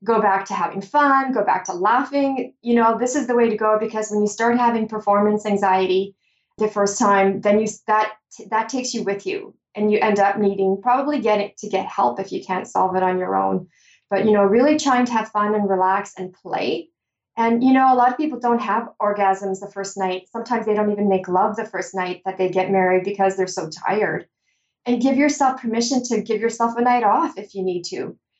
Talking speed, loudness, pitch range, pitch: 230 wpm, -20 LUFS, 195-235 Hz, 210 Hz